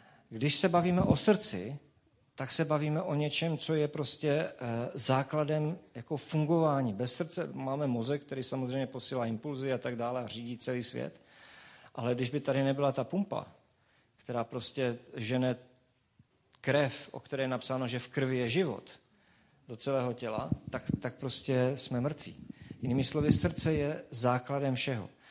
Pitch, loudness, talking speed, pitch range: 135 Hz, -33 LUFS, 155 wpm, 125-150 Hz